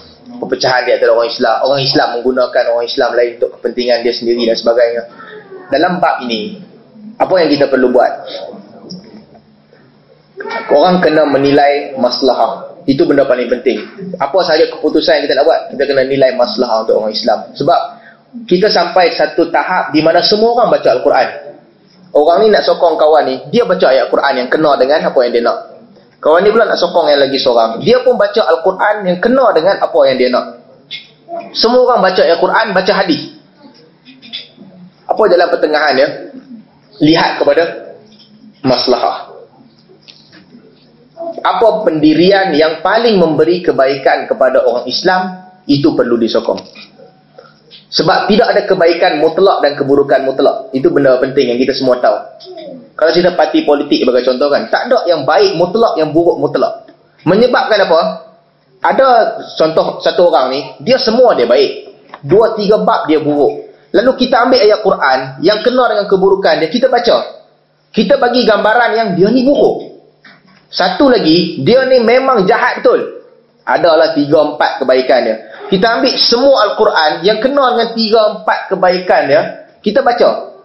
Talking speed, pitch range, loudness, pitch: 155 wpm, 155-240 Hz, -11 LUFS, 190 Hz